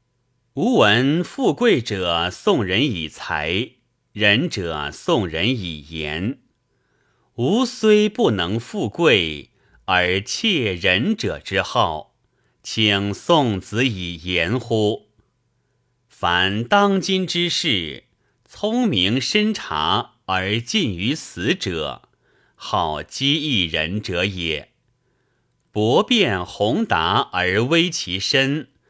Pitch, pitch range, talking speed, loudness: 120 Hz, 95-150 Hz, 125 characters per minute, -20 LUFS